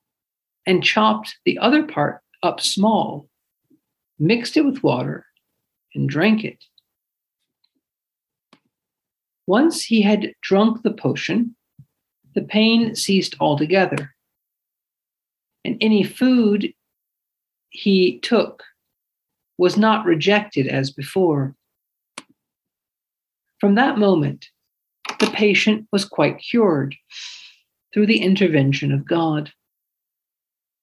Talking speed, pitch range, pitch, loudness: 90 wpm, 155-220 Hz, 200 Hz, -19 LUFS